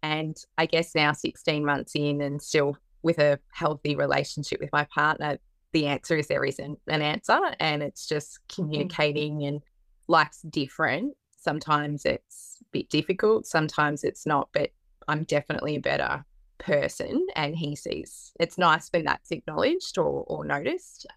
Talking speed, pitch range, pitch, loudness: 155 wpm, 145-165 Hz, 150 Hz, -27 LUFS